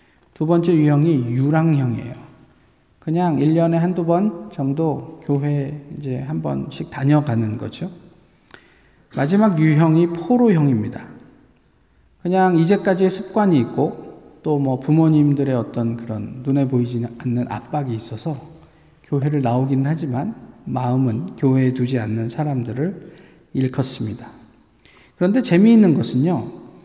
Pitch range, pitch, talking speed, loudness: 125-165 Hz, 145 Hz, 270 characters per minute, -19 LUFS